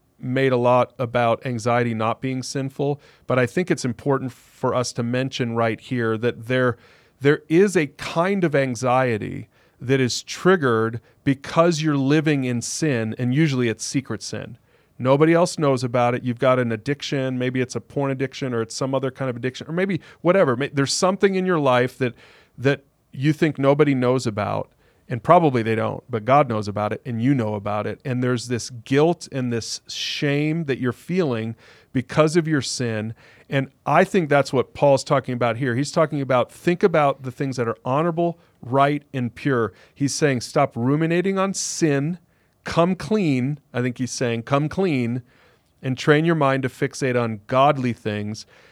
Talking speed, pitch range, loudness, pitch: 185 wpm, 120-150 Hz, -22 LUFS, 130 Hz